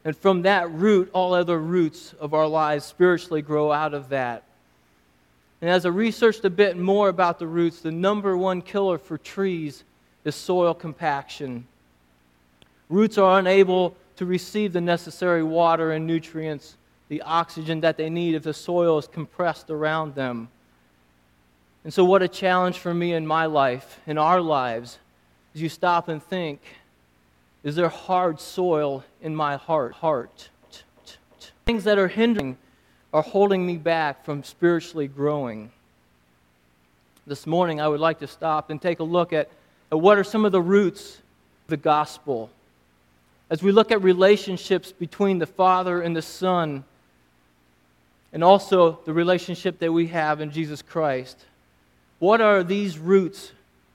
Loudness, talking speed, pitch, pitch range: -22 LUFS, 155 wpm, 160 Hz, 130-180 Hz